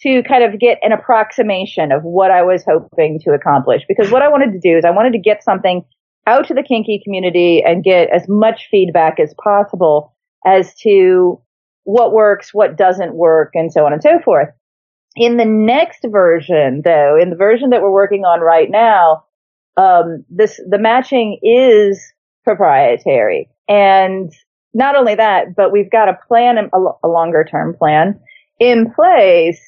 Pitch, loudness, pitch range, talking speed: 205 Hz, -12 LUFS, 175-245 Hz, 175 wpm